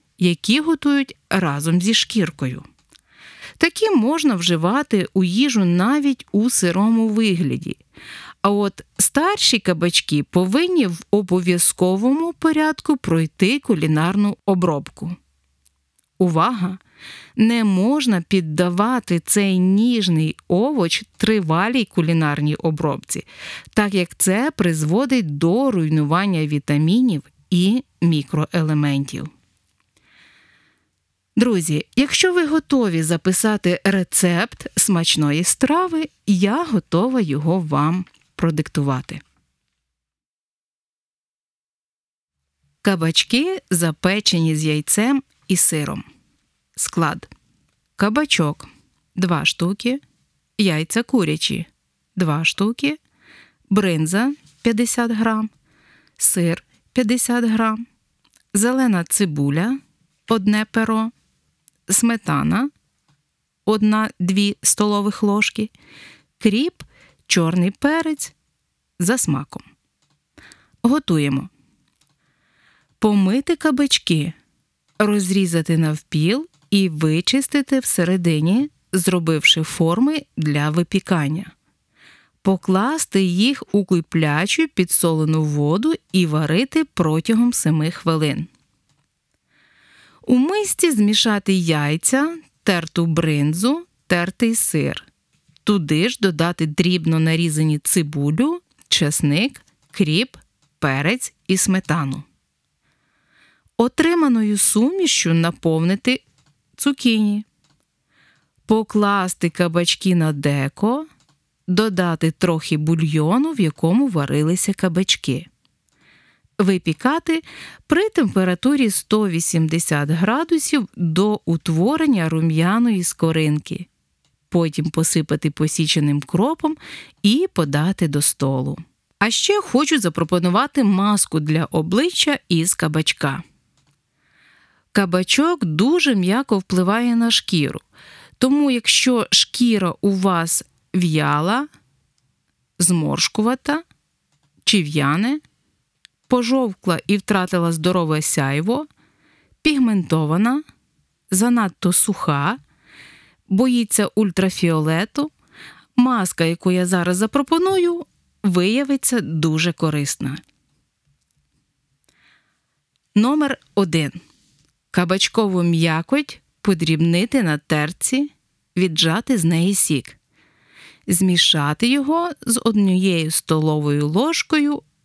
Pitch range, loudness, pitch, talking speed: 160-235 Hz, -18 LUFS, 185 Hz, 75 wpm